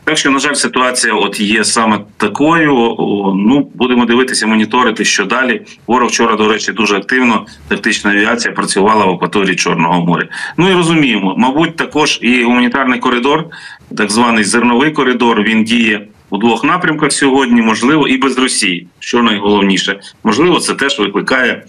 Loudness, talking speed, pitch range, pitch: -11 LUFS, 155 wpm, 105-135 Hz, 120 Hz